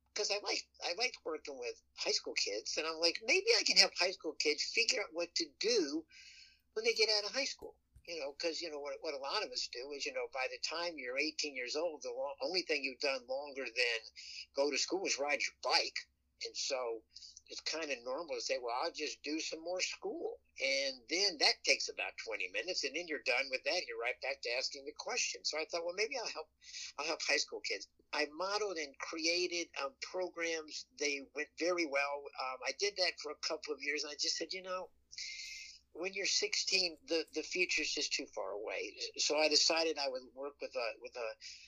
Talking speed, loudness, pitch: 235 wpm, -36 LUFS, 310 Hz